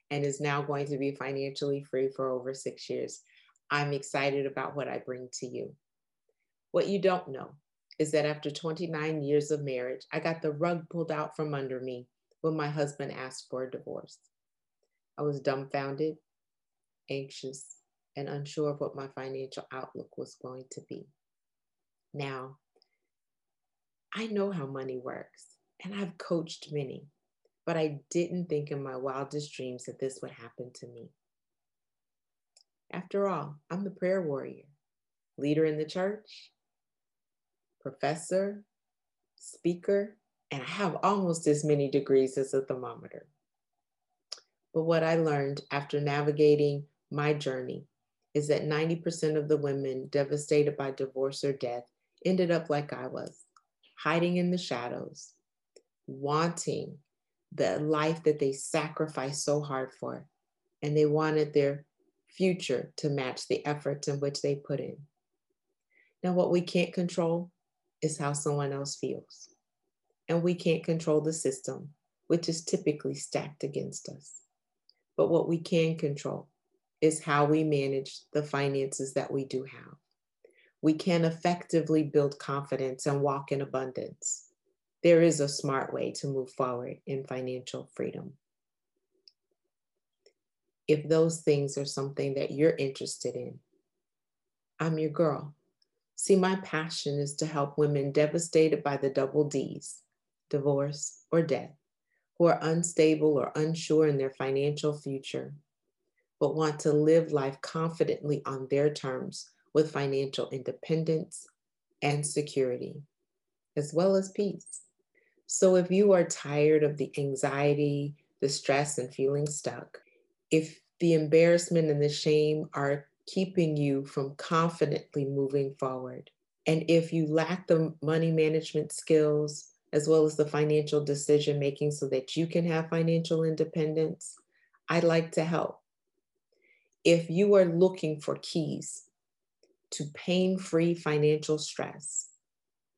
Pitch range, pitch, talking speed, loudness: 140-170 Hz, 150 Hz, 140 wpm, -30 LUFS